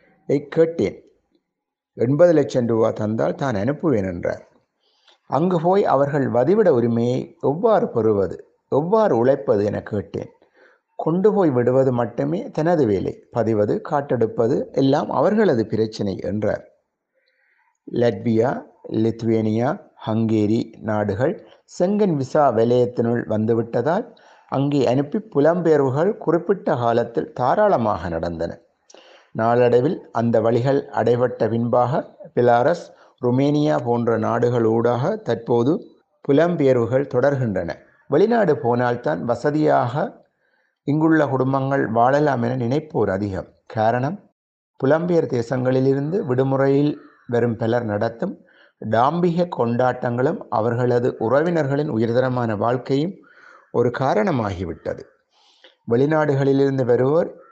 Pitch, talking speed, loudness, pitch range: 130 Hz, 90 wpm, -20 LUFS, 115-155 Hz